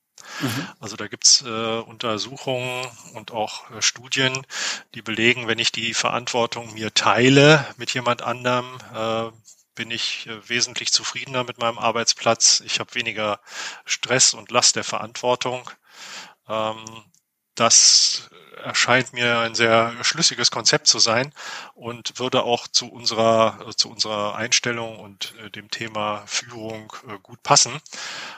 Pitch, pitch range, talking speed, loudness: 115 Hz, 110-125 Hz, 135 wpm, -19 LUFS